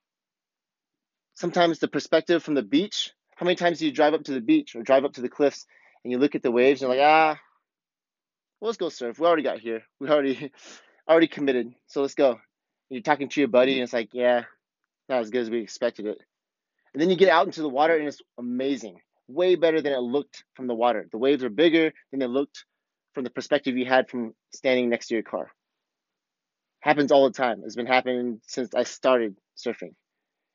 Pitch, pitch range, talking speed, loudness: 135 Hz, 125-155 Hz, 220 wpm, -24 LUFS